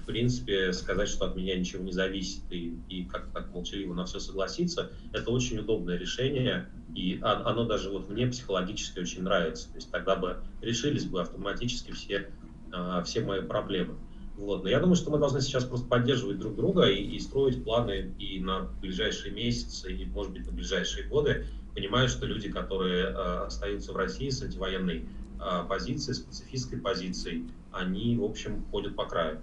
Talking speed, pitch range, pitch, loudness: 170 wpm, 90-120 Hz, 100 Hz, -31 LUFS